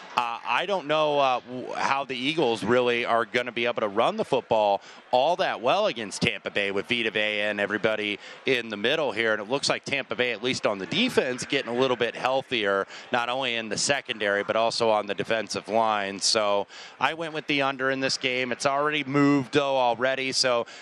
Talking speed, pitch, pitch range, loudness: 215 wpm, 120 Hz, 105-135 Hz, -25 LUFS